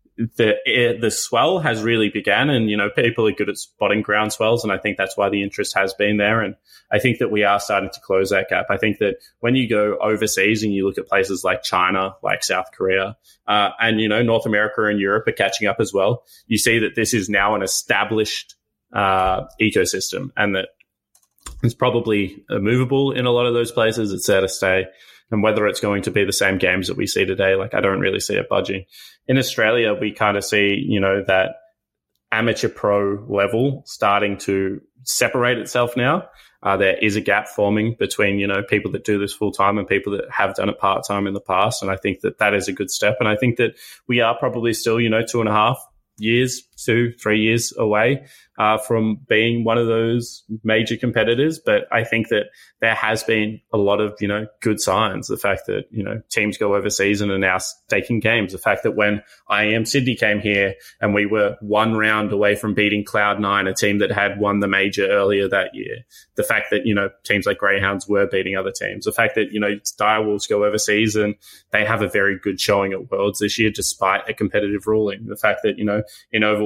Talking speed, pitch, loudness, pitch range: 225 wpm, 105 Hz, -19 LUFS, 100-115 Hz